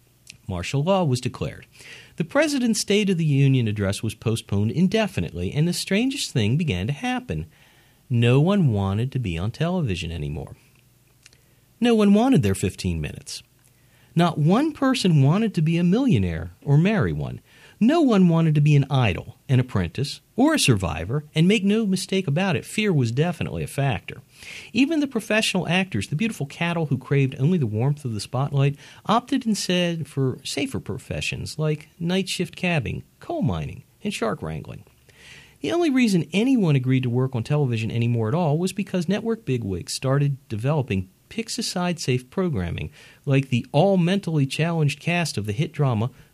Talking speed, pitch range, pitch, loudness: 170 wpm, 125-185 Hz, 145 Hz, -23 LUFS